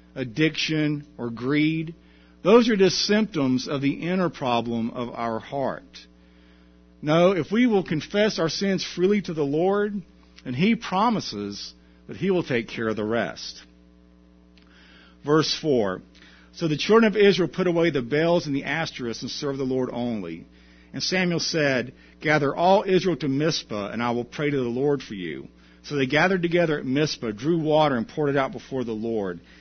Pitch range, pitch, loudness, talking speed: 110-170 Hz, 140 Hz, -24 LUFS, 175 wpm